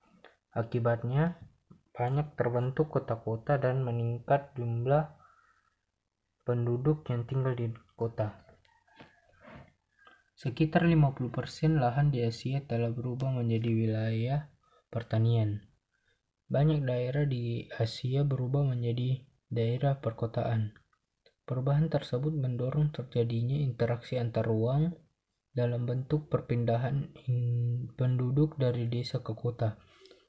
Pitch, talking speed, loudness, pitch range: 125 Hz, 90 wpm, -31 LUFS, 115-140 Hz